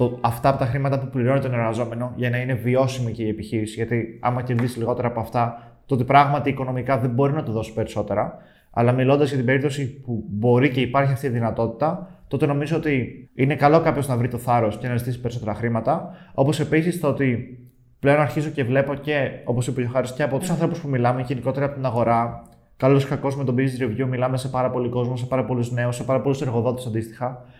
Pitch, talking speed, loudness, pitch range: 130 Hz, 220 wpm, -22 LUFS, 120-140 Hz